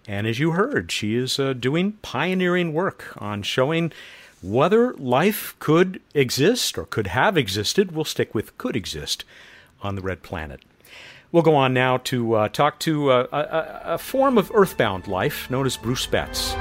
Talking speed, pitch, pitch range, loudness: 175 wpm, 145 Hz, 125-180 Hz, -22 LUFS